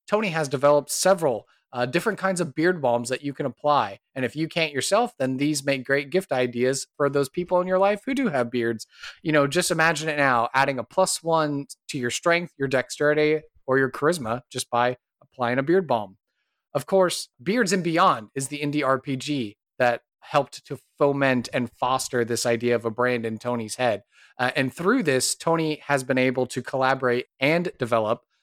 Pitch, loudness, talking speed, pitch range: 140 Hz, -24 LUFS, 200 wpm, 125-160 Hz